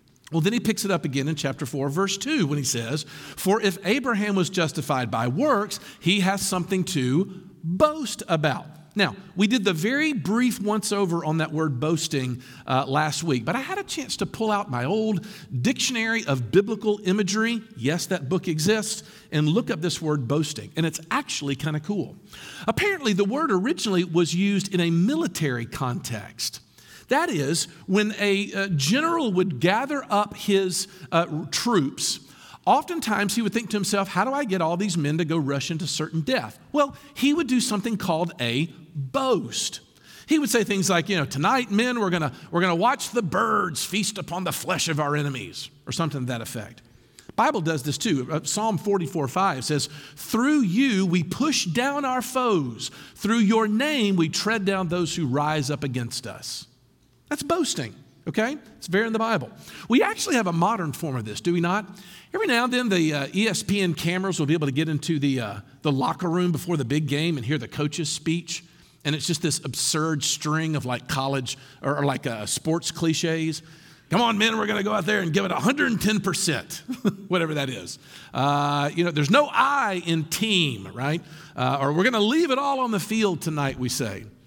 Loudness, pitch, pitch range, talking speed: -24 LUFS, 175 Hz, 150-210 Hz, 195 wpm